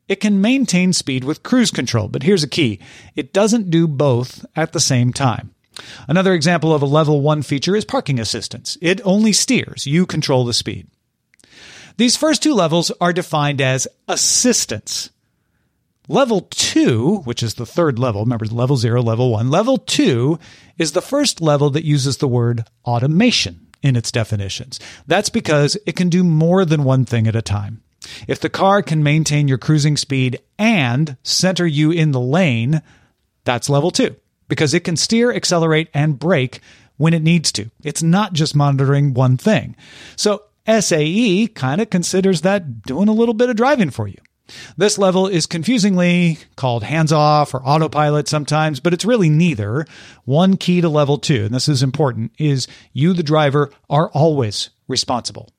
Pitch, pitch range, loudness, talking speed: 150 Hz, 130-180 Hz, -16 LUFS, 175 wpm